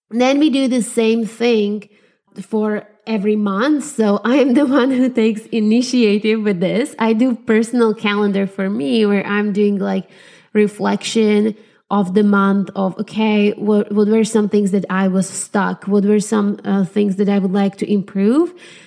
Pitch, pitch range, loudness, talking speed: 210 Hz, 200-225 Hz, -16 LUFS, 175 wpm